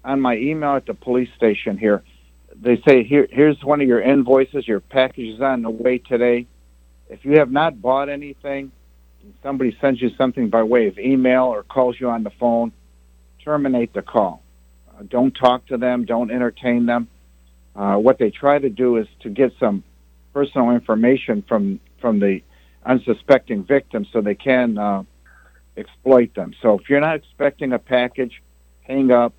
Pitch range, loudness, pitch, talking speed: 105-135 Hz, -18 LUFS, 125 Hz, 180 wpm